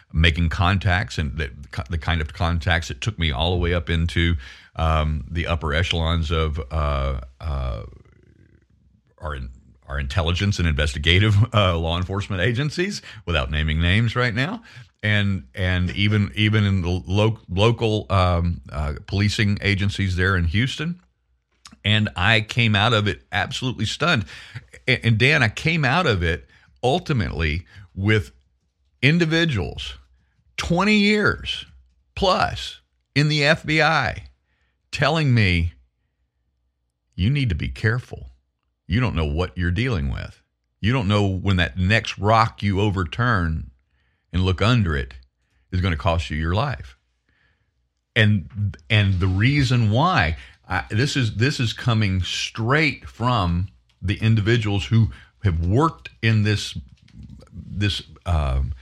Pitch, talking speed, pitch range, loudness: 95 Hz, 135 wpm, 80-110 Hz, -21 LUFS